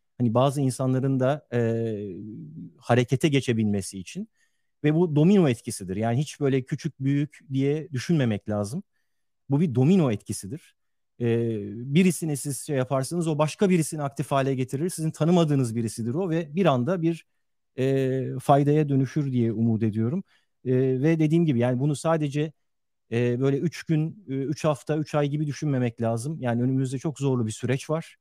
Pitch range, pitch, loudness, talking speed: 120-155 Hz, 135 Hz, -25 LUFS, 155 wpm